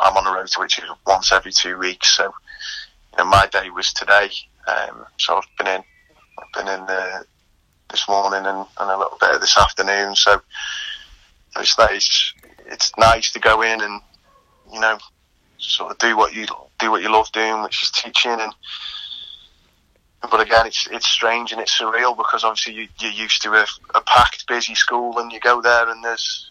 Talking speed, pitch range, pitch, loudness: 195 wpm, 95-115 Hz, 110 Hz, -17 LUFS